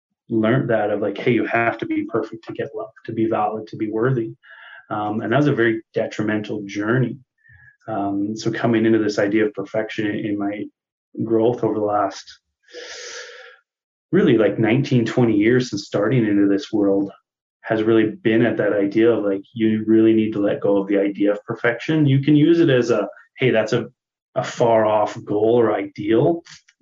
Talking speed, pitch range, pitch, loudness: 190 wpm, 105-120 Hz, 110 Hz, -20 LUFS